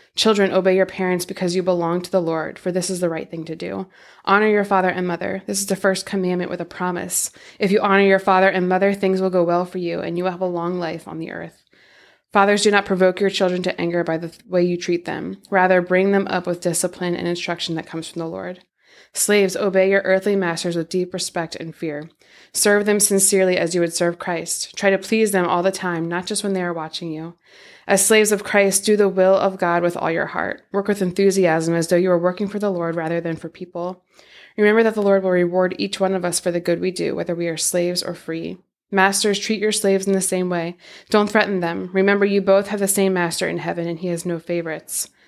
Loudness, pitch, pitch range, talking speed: -19 LUFS, 185 Hz, 175-195 Hz, 250 wpm